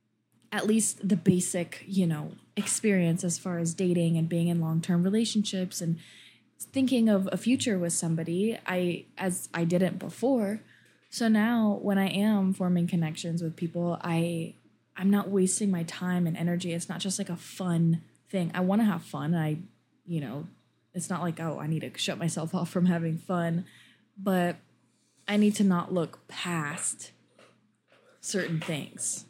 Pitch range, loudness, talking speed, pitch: 170-195 Hz, -29 LUFS, 170 wpm, 180 Hz